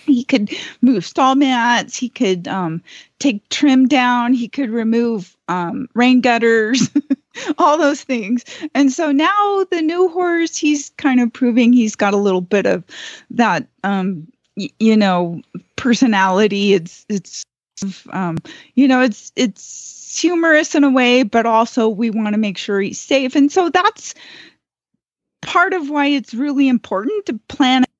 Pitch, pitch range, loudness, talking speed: 250 Hz, 215-285 Hz, -16 LUFS, 155 wpm